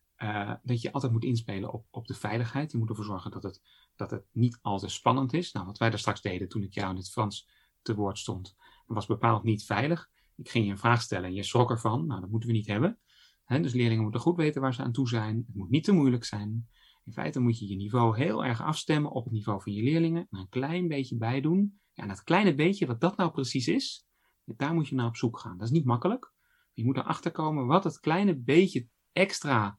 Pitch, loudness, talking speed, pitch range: 120 Hz, -29 LUFS, 250 wpm, 105-150 Hz